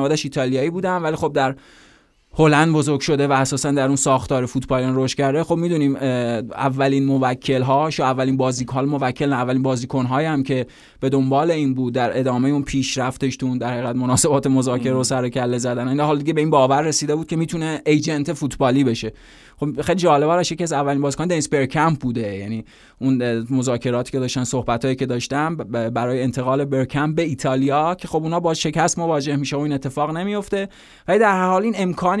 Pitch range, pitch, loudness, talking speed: 130-155 Hz, 135 Hz, -20 LUFS, 190 wpm